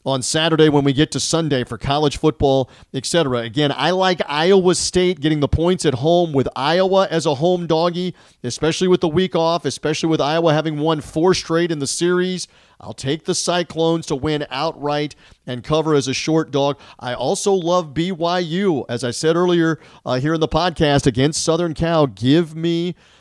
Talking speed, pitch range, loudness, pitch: 190 wpm, 140-175 Hz, -18 LUFS, 160 Hz